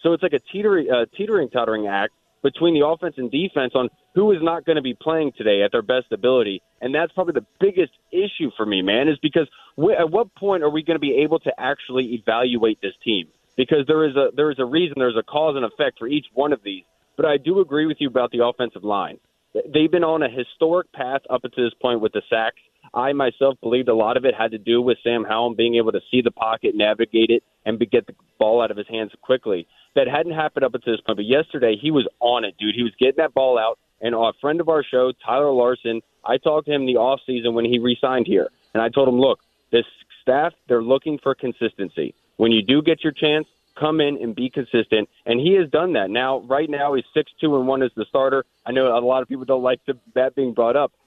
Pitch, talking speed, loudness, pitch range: 130 Hz, 250 wpm, -20 LUFS, 120-155 Hz